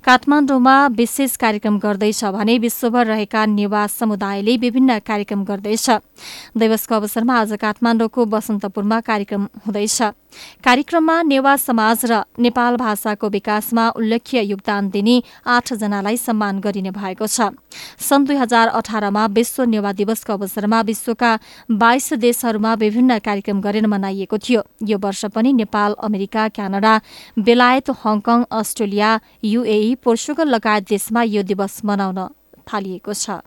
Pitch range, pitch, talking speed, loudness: 210-240 Hz, 220 Hz, 120 wpm, -17 LUFS